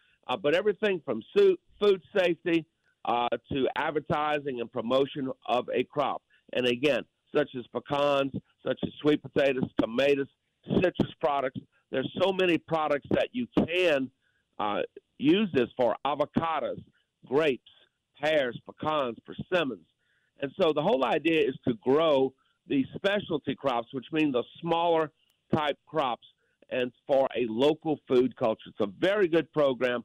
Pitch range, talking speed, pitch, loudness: 125-165 Hz, 140 wpm, 145 Hz, -28 LUFS